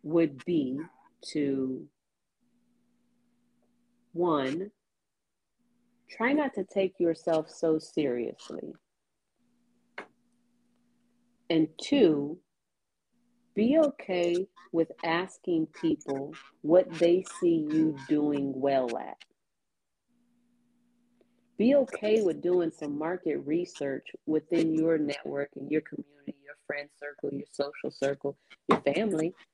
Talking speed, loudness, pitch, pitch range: 95 wpm, -29 LUFS, 170 Hz, 145-240 Hz